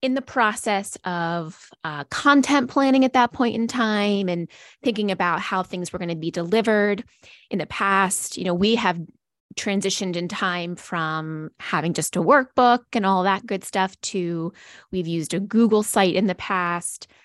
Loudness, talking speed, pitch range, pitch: -22 LUFS, 175 wpm, 175-230 Hz, 195 Hz